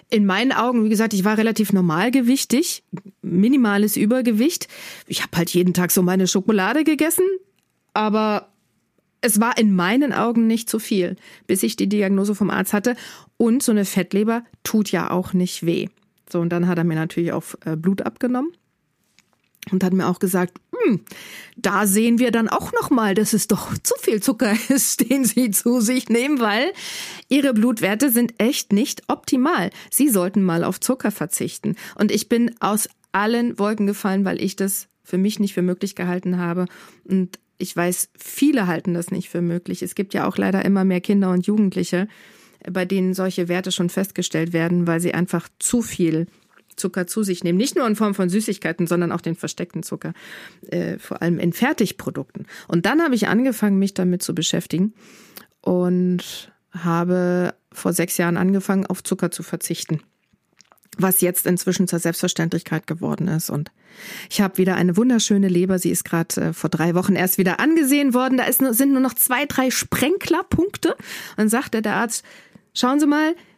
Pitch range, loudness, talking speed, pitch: 180-230 Hz, -20 LUFS, 180 wpm, 195 Hz